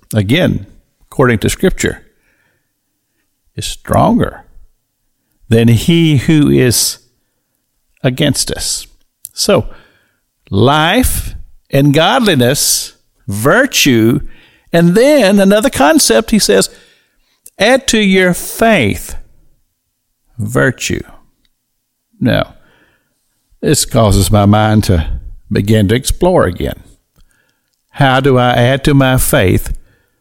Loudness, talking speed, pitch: -11 LUFS, 90 wpm, 130 Hz